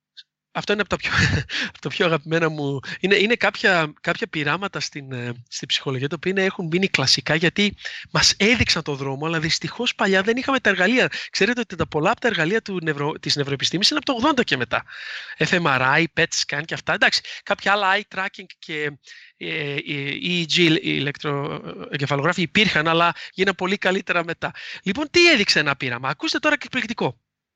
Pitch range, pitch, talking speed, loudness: 150-200 Hz, 170 Hz, 170 wpm, -20 LUFS